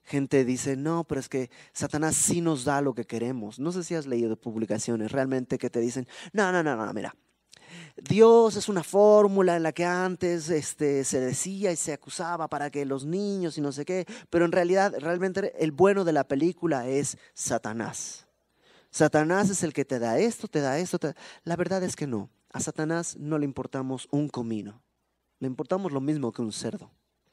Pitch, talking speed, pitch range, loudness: 155 Hz, 200 wpm, 135-180 Hz, -27 LUFS